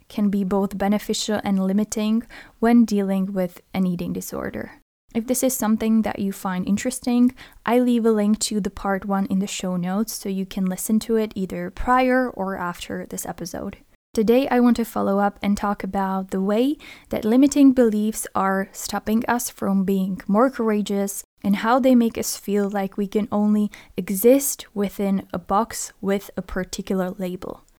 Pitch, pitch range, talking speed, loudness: 205 Hz, 195-230 Hz, 180 wpm, -22 LUFS